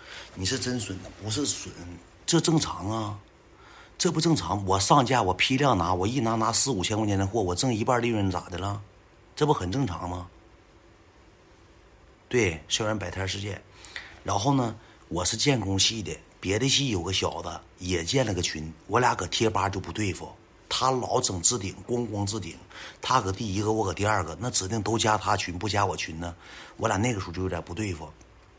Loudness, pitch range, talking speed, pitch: -26 LUFS, 90-115 Hz, 270 characters per minute, 100 Hz